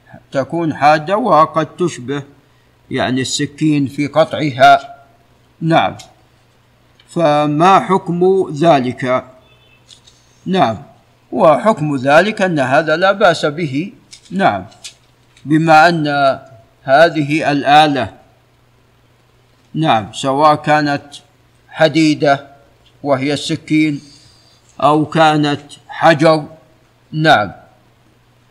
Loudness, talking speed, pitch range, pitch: -13 LUFS, 75 wpm, 130-160 Hz, 145 Hz